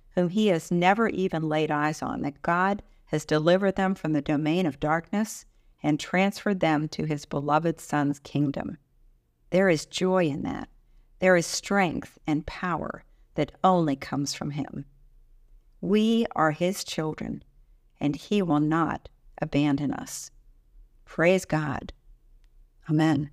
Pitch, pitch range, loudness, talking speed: 155 Hz, 145-185 Hz, -26 LUFS, 140 wpm